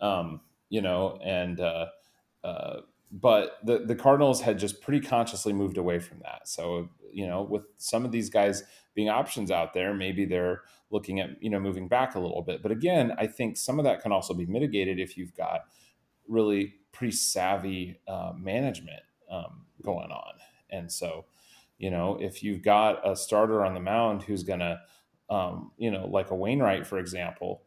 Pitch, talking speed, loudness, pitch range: 100 Hz, 185 wpm, -29 LUFS, 90-110 Hz